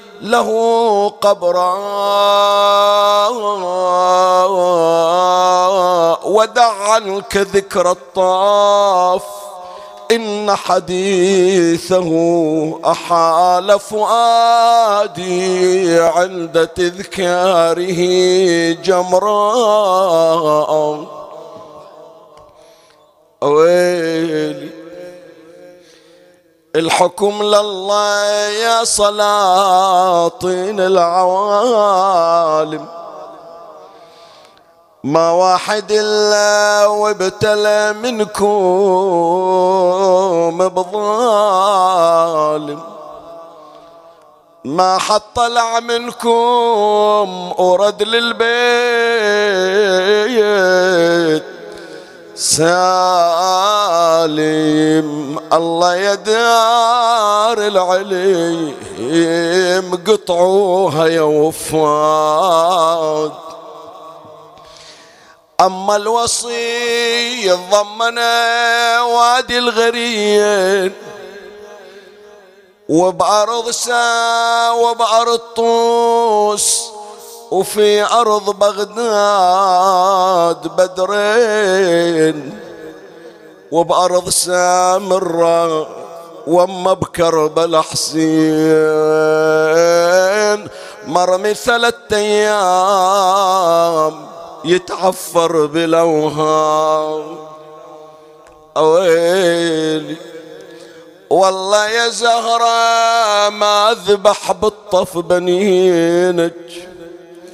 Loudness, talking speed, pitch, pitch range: -13 LUFS, 40 wpm, 185 Hz, 170-210 Hz